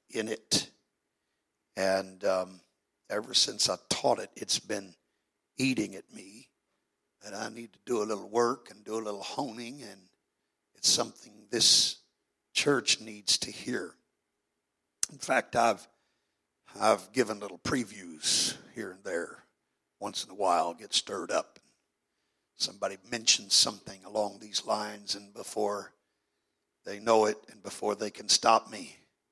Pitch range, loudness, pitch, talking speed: 100-110 Hz, -29 LUFS, 105 Hz, 145 wpm